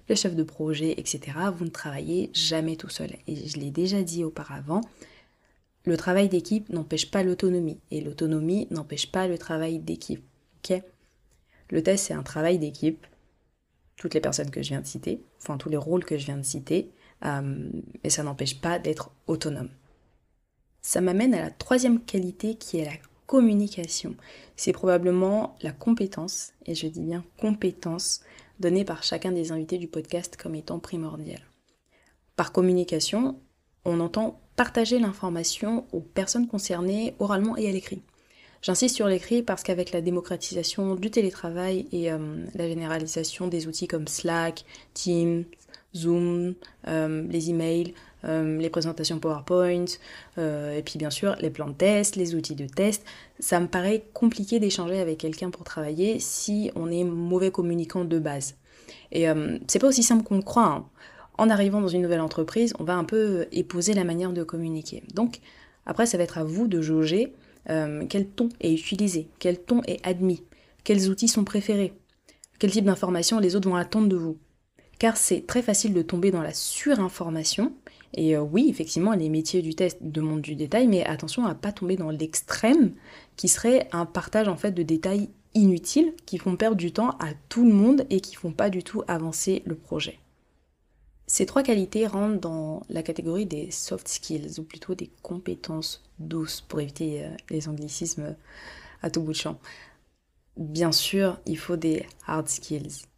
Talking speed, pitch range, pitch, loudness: 175 wpm, 160-200 Hz, 175 Hz, -26 LUFS